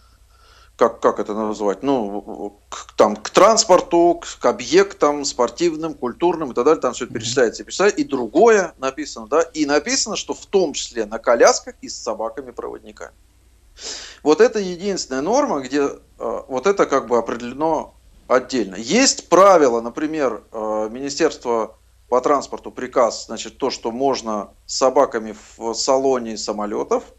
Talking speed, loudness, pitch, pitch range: 140 wpm, -19 LUFS, 135 Hz, 115-165 Hz